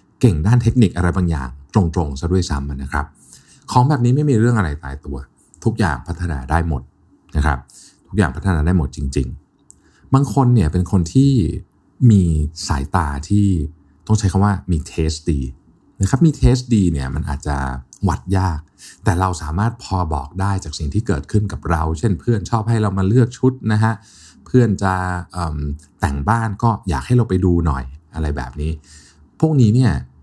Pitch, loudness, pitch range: 90 Hz, -18 LUFS, 75-105 Hz